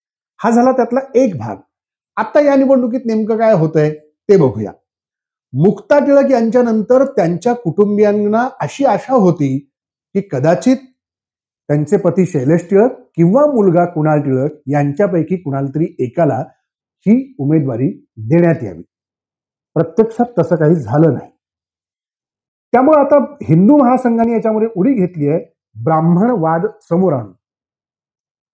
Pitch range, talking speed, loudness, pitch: 150-240 Hz, 120 wpm, -14 LUFS, 180 Hz